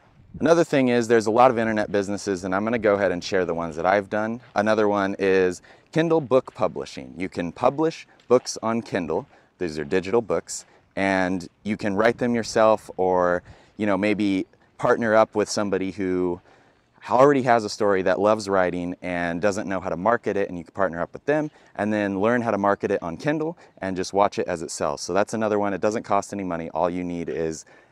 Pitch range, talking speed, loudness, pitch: 95-115 Hz, 220 wpm, -23 LUFS, 100 Hz